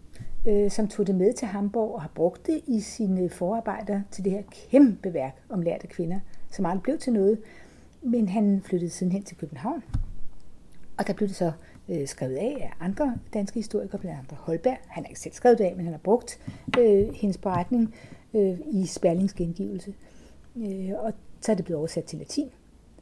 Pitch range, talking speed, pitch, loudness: 180-220 Hz, 185 wpm, 200 Hz, -27 LUFS